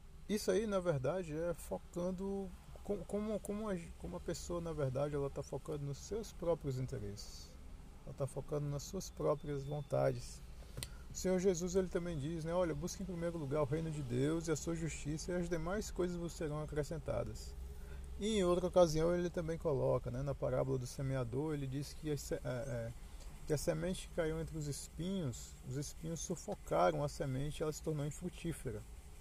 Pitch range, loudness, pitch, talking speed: 135-175 Hz, -40 LUFS, 155 Hz, 190 wpm